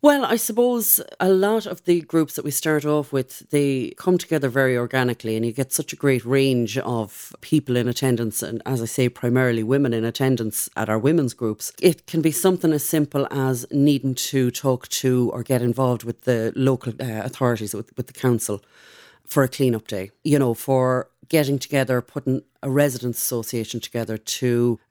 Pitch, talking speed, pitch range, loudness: 130 Hz, 195 wpm, 120-145 Hz, -22 LUFS